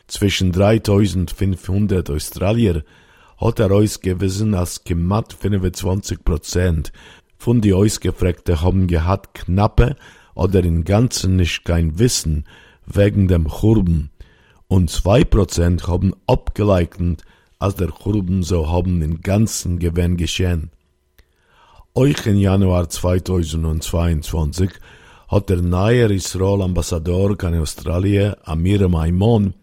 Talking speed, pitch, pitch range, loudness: 100 wpm, 90 Hz, 85-100 Hz, -18 LUFS